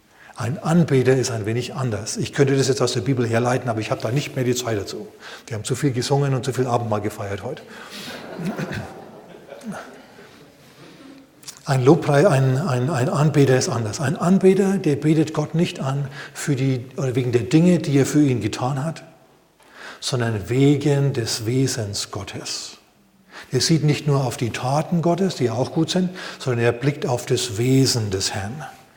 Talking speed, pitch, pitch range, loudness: 180 wpm, 135 Hz, 125-150 Hz, -21 LUFS